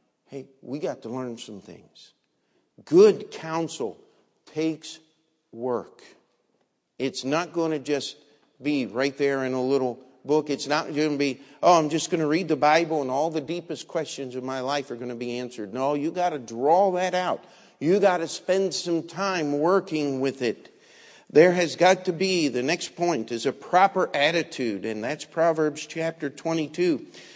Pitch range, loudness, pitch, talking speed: 135-170 Hz, -25 LUFS, 155 Hz, 180 wpm